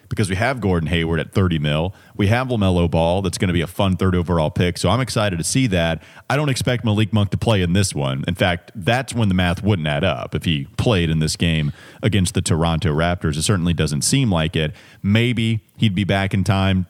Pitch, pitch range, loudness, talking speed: 95 Hz, 85-110 Hz, -19 LUFS, 240 wpm